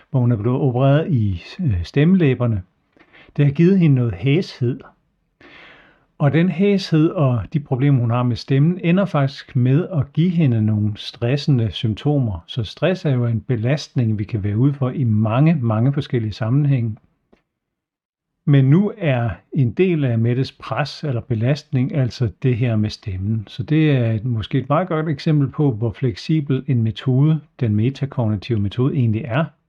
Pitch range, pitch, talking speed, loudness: 115-150 Hz, 135 Hz, 165 wpm, -19 LUFS